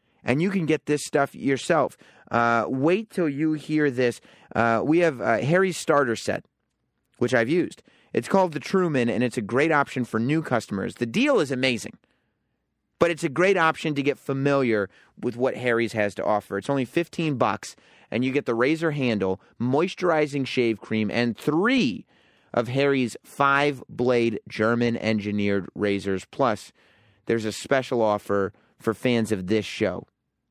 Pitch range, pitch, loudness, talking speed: 115-150 Hz, 125 Hz, -24 LUFS, 165 wpm